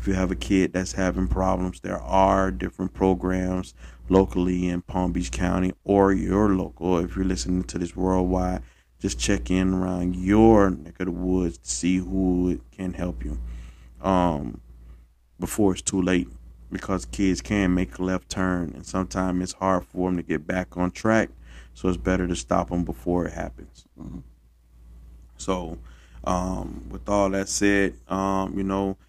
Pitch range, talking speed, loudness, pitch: 85-95 Hz, 170 wpm, -24 LUFS, 90 Hz